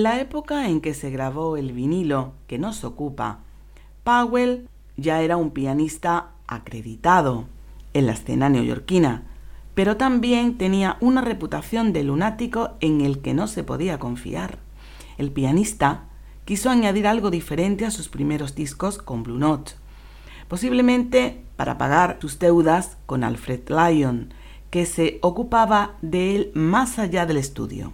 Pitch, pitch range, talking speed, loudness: 165 Hz, 140-210 Hz, 140 wpm, -22 LUFS